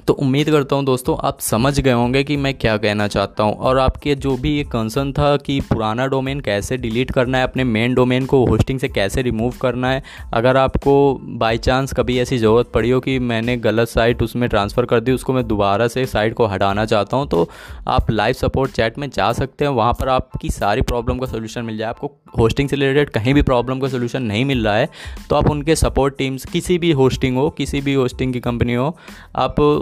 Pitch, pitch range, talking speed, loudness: 130 Hz, 115-135 Hz, 225 wpm, -18 LUFS